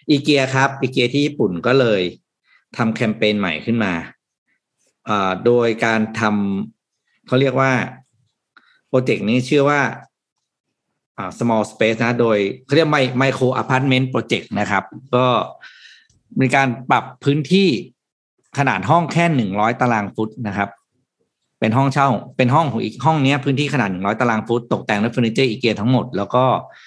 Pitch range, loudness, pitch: 110-135 Hz, -18 LUFS, 125 Hz